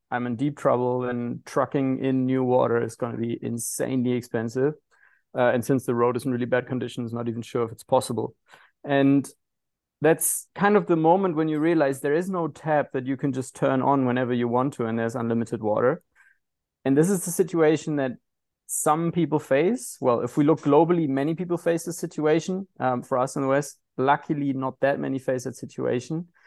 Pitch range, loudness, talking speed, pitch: 125-155 Hz, -24 LUFS, 205 wpm, 135 Hz